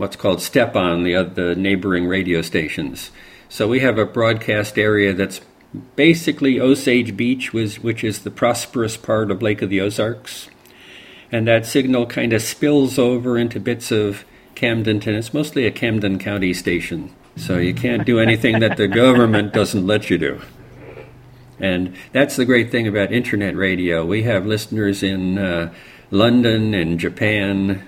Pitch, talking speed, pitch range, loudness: 110 Hz, 165 wpm, 95-120 Hz, -18 LUFS